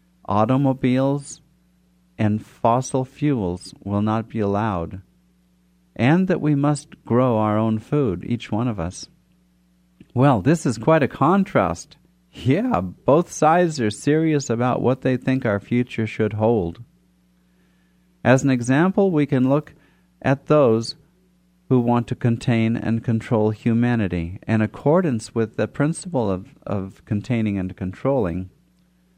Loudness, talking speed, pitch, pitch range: -21 LUFS, 130 wpm, 120 Hz, 100-145 Hz